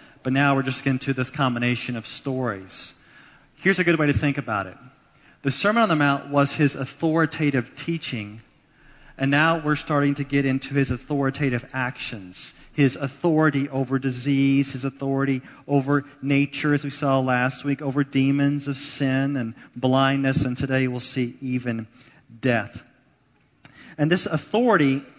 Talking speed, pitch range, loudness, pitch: 155 wpm, 130-145 Hz, -23 LUFS, 135 Hz